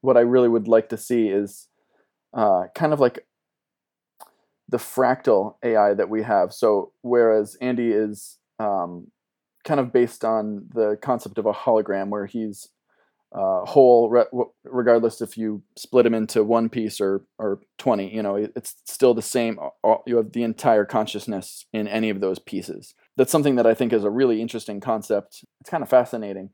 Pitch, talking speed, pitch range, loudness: 110 Hz, 175 wpm, 105-120 Hz, -22 LUFS